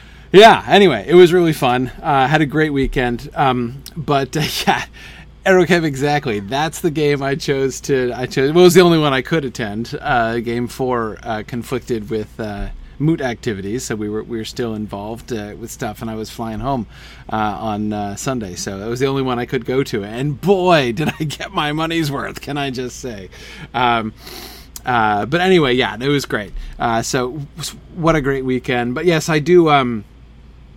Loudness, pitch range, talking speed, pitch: -17 LUFS, 115-150 Hz, 205 wpm, 130 Hz